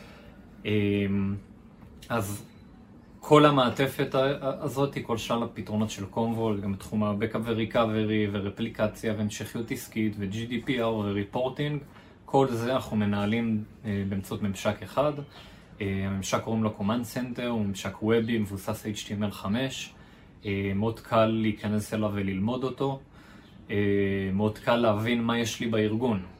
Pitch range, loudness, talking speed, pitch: 100-120 Hz, -28 LUFS, 110 wpm, 110 Hz